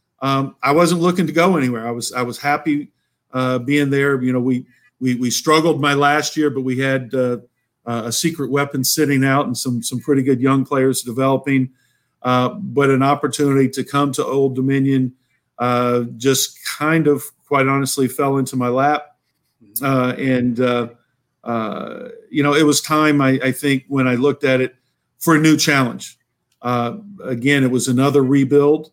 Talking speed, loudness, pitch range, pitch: 180 wpm, -17 LUFS, 125-145 Hz, 135 Hz